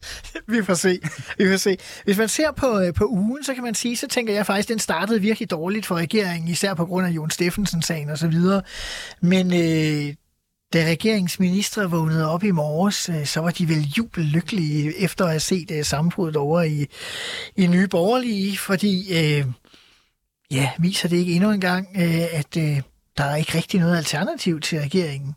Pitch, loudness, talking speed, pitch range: 180 Hz, -22 LUFS, 175 wpm, 160-200 Hz